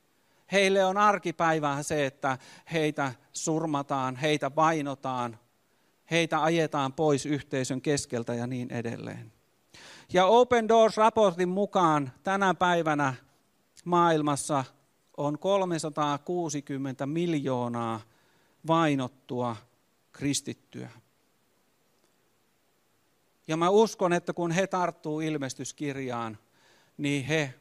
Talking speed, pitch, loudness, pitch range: 85 wpm, 150 Hz, -27 LUFS, 135-170 Hz